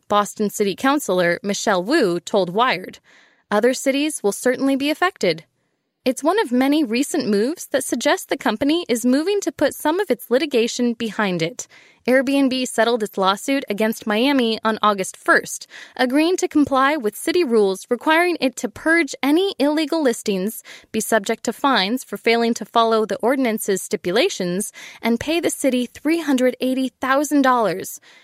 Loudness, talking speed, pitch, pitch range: -19 LUFS, 155 wpm, 250 Hz, 220-285 Hz